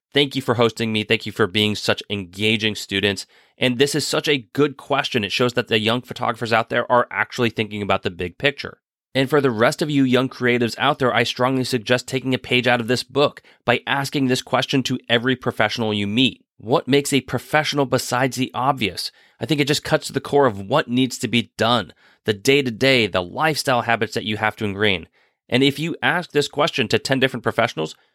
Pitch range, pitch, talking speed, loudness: 110-135 Hz, 125 Hz, 225 wpm, -20 LUFS